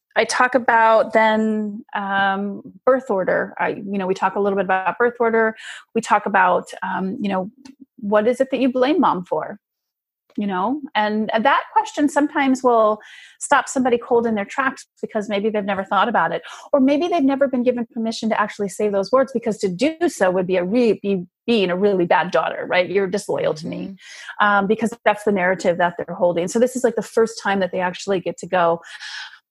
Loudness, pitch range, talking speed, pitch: -19 LUFS, 195-250 Hz, 210 wpm, 215 Hz